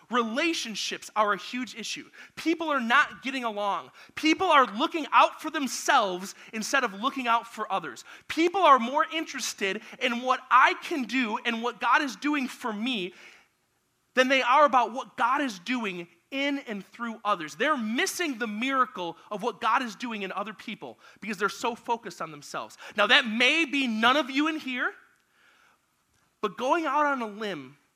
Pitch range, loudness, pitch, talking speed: 215-280 Hz, -26 LUFS, 245 Hz, 180 wpm